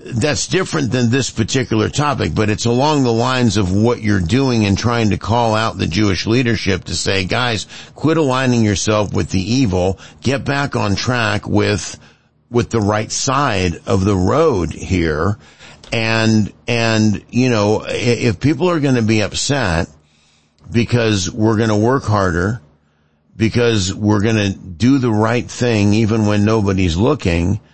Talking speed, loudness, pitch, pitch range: 160 wpm, -16 LUFS, 110 Hz, 95-120 Hz